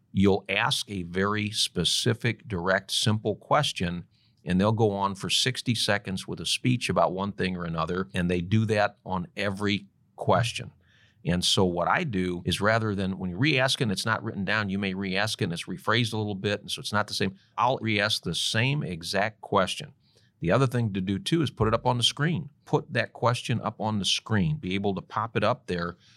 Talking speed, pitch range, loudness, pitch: 215 wpm, 95-115 Hz, -27 LUFS, 105 Hz